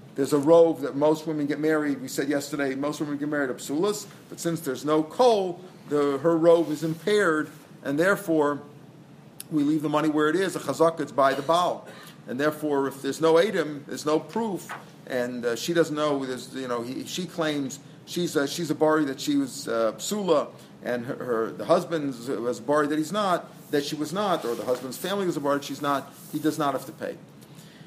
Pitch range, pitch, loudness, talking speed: 140-165 Hz, 150 Hz, -26 LUFS, 220 wpm